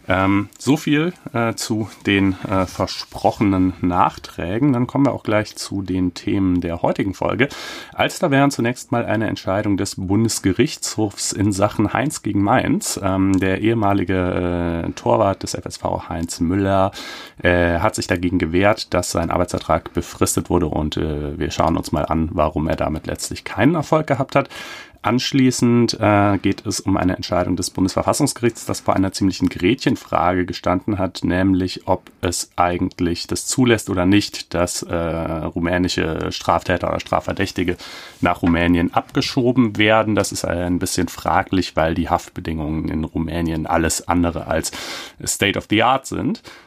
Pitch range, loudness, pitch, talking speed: 90-110 Hz, -19 LUFS, 95 Hz, 155 wpm